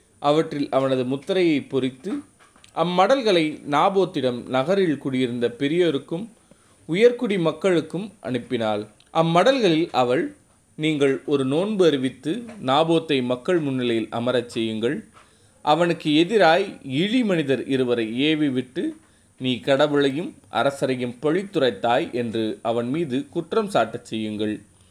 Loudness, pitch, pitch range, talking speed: -22 LUFS, 140 Hz, 125-170 Hz, 95 wpm